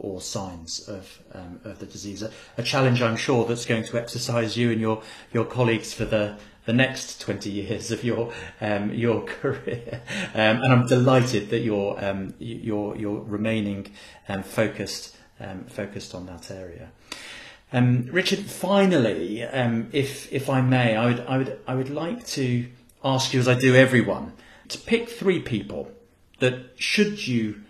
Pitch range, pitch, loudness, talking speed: 105-130 Hz, 115 Hz, -24 LUFS, 170 wpm